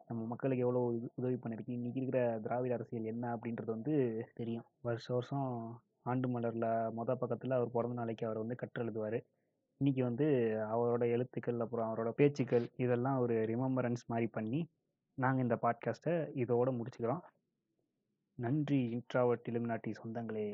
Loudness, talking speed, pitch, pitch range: -37 LUFS, 135 wpm, 120 Hz, 115-125 Hz